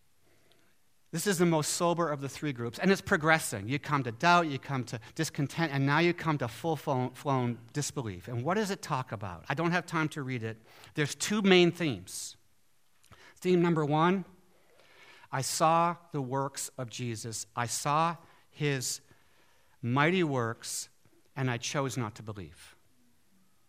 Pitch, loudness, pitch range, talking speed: 145 Hz, -30 LUFS, 120-165 Hz, 165 wpm